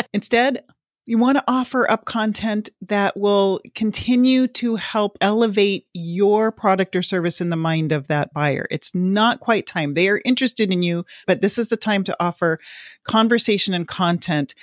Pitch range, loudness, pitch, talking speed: 175-230 Hz, -19 LUFS, 205 Hz, 170 wpm